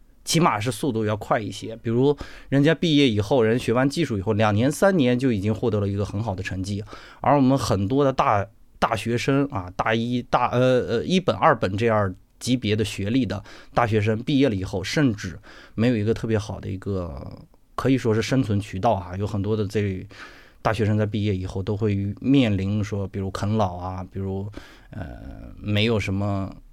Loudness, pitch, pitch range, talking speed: -23 LUFS, 110 Hz, 100-125 Hz, 285 characters per minute